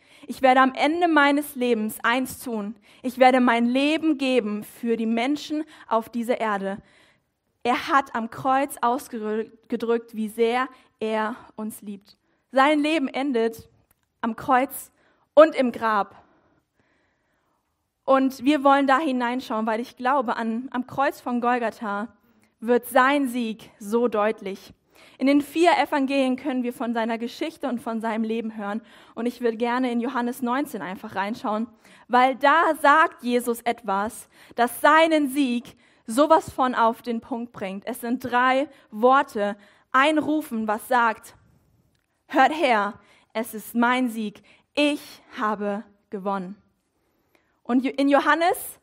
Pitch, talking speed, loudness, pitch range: 245 Hz, 140 wpm, -23 LUFS, 225-275 Hz